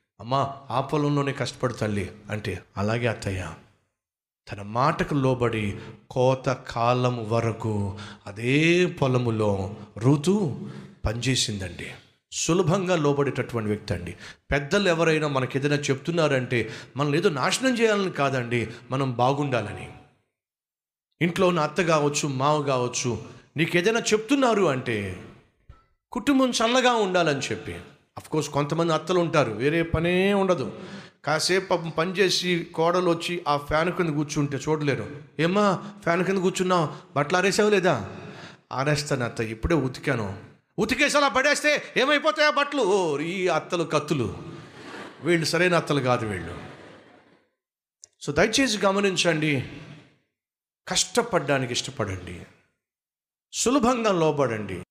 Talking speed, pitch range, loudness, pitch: 100 wpm, 120-180 Hz, -24 LUFS, 145 Hz